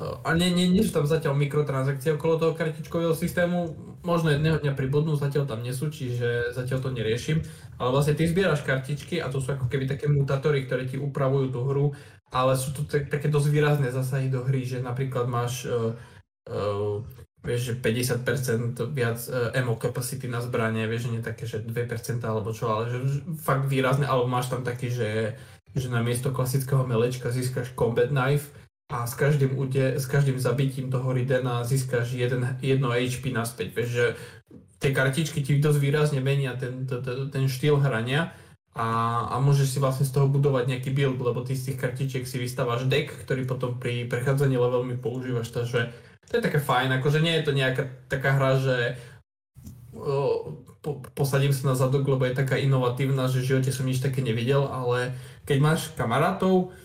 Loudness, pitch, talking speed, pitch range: -26 LUFS, 130 Hz, 185 wpm, 120-145 Hz